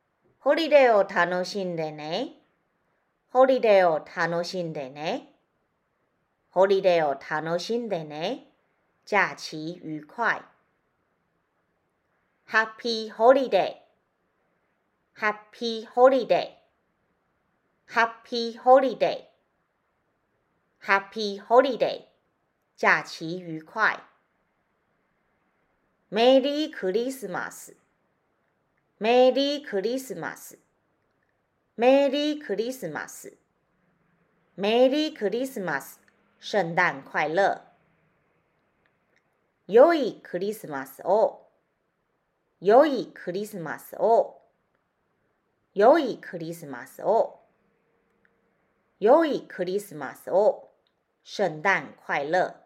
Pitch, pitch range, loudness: 210 Hz, 175-255 Hz, -24 LUFS